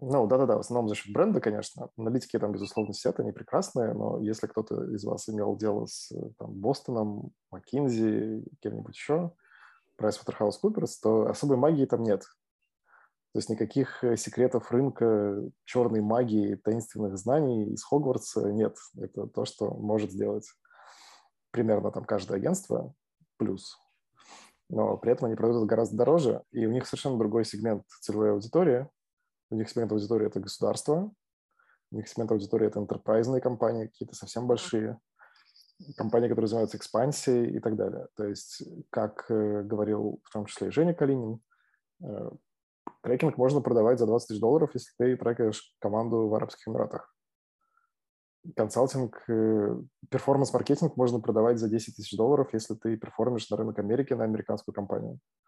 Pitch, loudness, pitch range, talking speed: 115 Hz, -29 LUFS, 110-125 Hz, 145 wpm